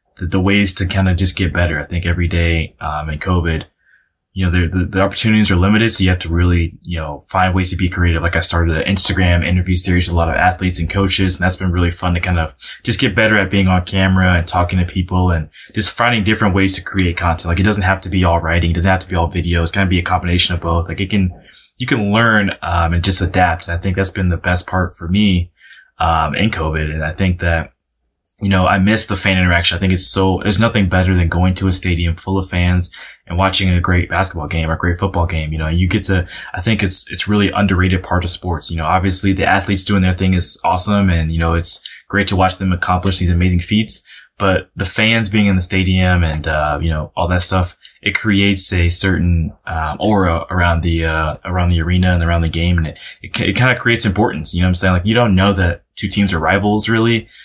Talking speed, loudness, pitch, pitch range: 260 wpm, -15 LUFS, 90 Hz, 85-95 Hz